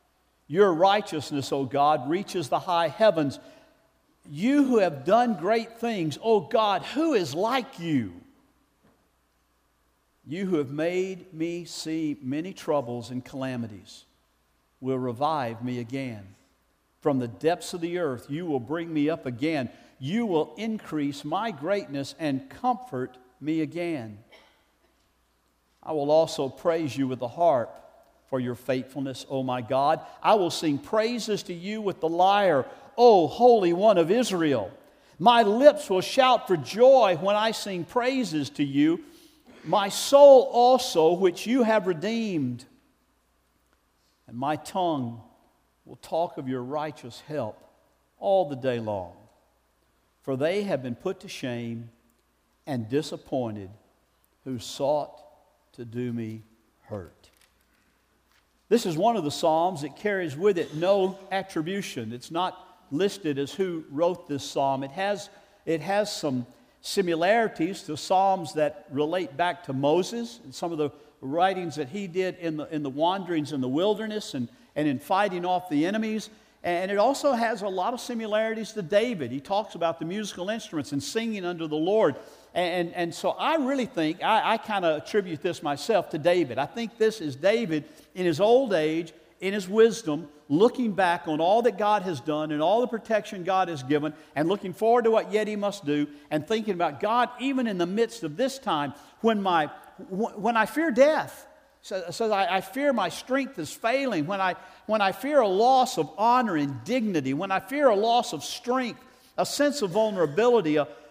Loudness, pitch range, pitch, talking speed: -26 LUFS, 145-215 Hz, 175 Hz, 170 wpm